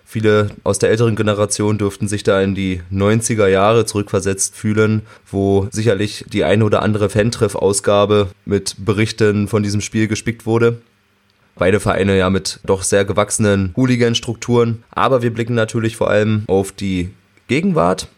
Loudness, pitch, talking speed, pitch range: -16 LUFS, 105 Hz, 150 wpm, 100-110 Hz